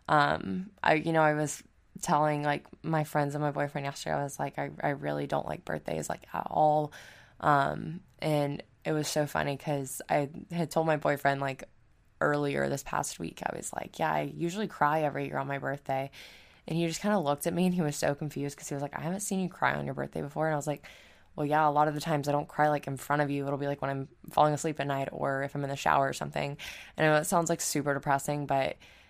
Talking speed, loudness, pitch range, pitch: 260 wpm, -31 LUFS, 140-155 Hz, 145 Hz